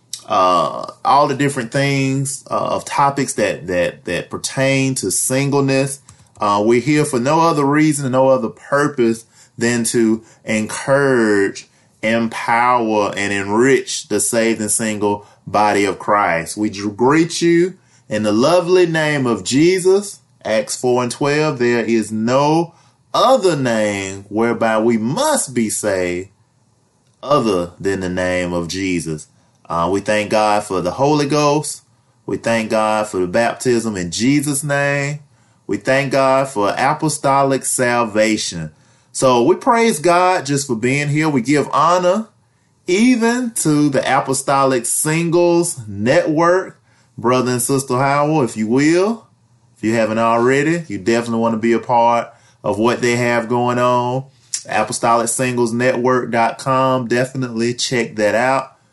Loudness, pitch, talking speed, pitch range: -16 LUFS, 125 Hz, 140 wpm, 110-140 Hz